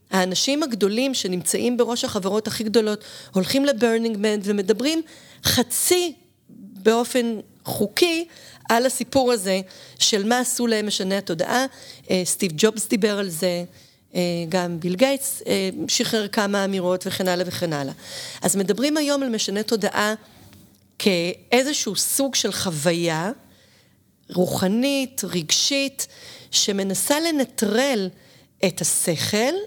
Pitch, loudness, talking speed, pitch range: 215 Hz, -22 LUFS, 110 wpm, 190-250 Hz